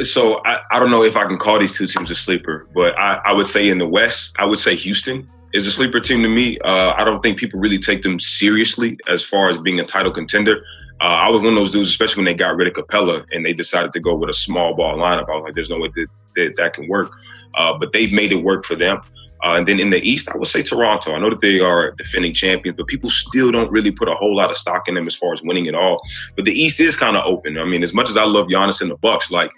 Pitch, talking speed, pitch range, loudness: 100 Hz, 295 wpm, 95-110 Hz, -16 LUFS